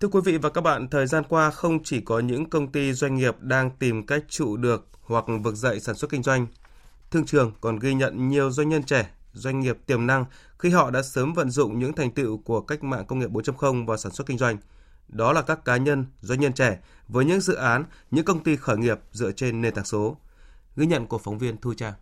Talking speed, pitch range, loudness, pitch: 250 wpm, 115-145 Hz, -24 LUFS, 130 Hz